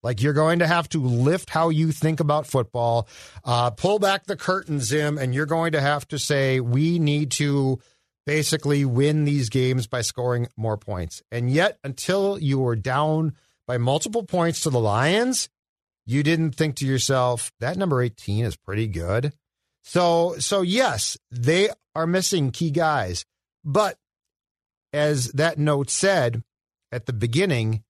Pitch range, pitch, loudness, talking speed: 120-160 Hz, 140 Hz, -23 LUFS, 160 wpm